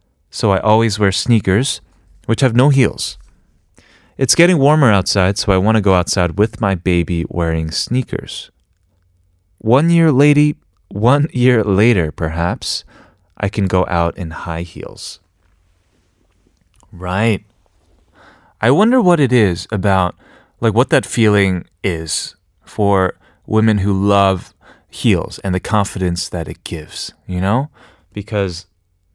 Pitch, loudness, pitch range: 95 Hz, -16 LUFS, 90-115 Hz